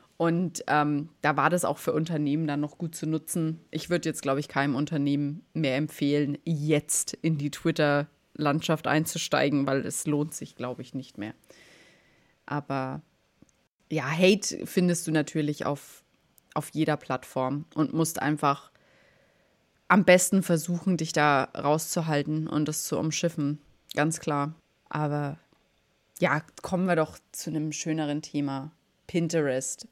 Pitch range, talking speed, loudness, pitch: 145-165 Hz, 140 wpm, -27 LUFS, 155 Hz